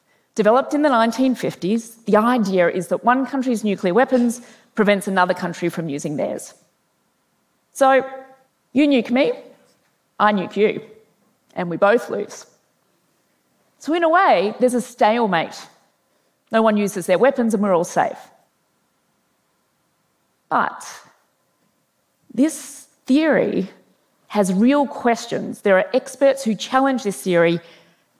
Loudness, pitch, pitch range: -19 LUFS, 230 Hz, 200-265 Hz